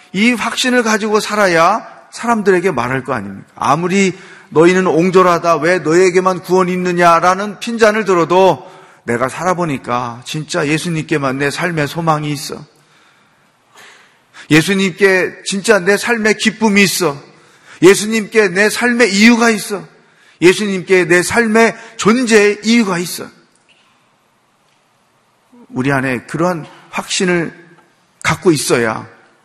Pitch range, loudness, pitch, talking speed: 165-210 Hz, -13 LUFS, 185 Hz, 265 characters per minute